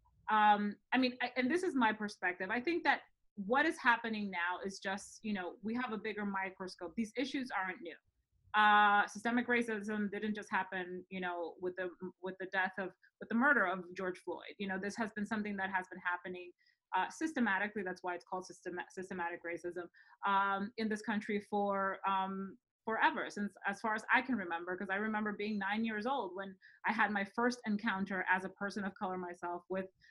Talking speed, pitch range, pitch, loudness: 205 wpm, 185-220 Hz, 200 Hz, -36 LUFS